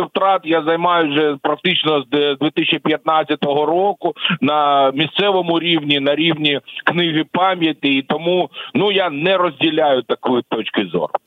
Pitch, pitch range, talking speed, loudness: 160 Hz, 150-175 Hz, 130 wpm, -16 LUFS